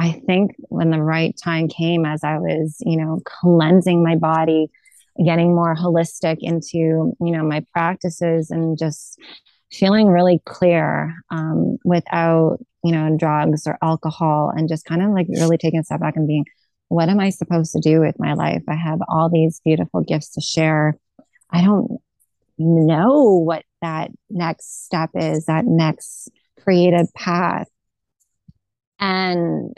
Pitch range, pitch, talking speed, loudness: 160-175 Hz, 165 Hz, 155 wpm, -18 LUFS